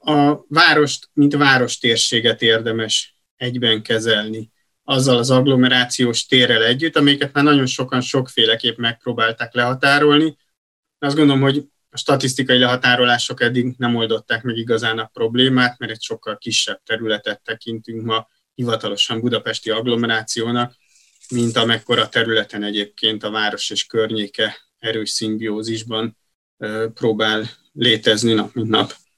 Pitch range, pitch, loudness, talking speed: 110-130 Hz, 120 Hz, -17 LUFS, 120 wpm